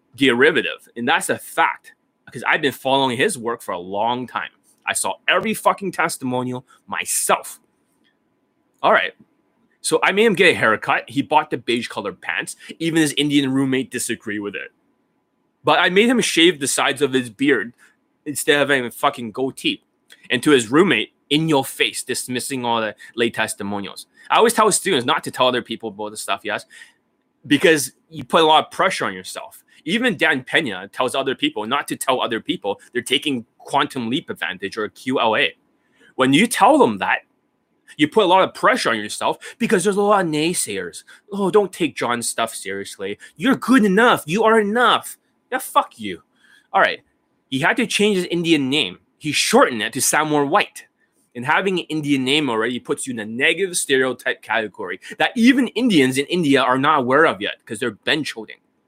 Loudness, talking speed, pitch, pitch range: -19 LUFS, 195 wpm, 150 Hz, 130-215 Hz